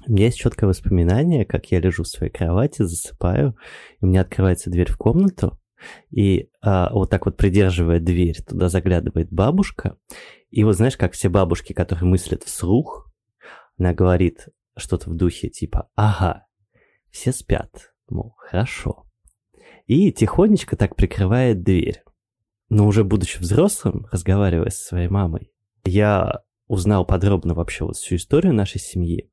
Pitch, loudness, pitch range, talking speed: 95 Hz, -20 LUFS, 90-110 Hz, 145 wpm